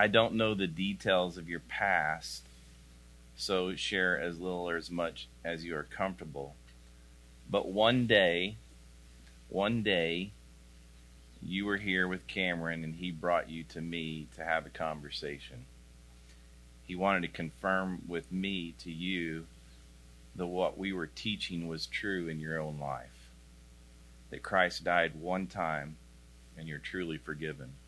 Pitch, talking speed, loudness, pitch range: 80 Hz, 145 wpm, -34 LUFS, 60-90 Hz